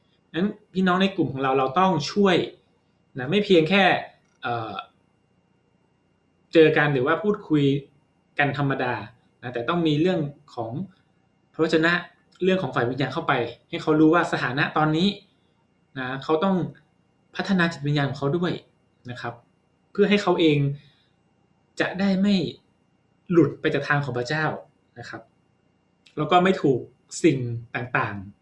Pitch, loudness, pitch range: 155 Hz, -23 LUFS, 140-180 Hz